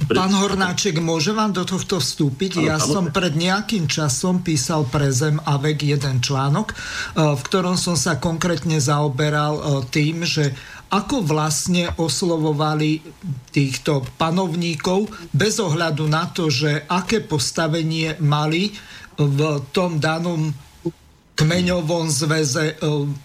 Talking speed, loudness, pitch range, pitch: 115 wpm, -20 LUFS, 150-180 Hz, 160 Hz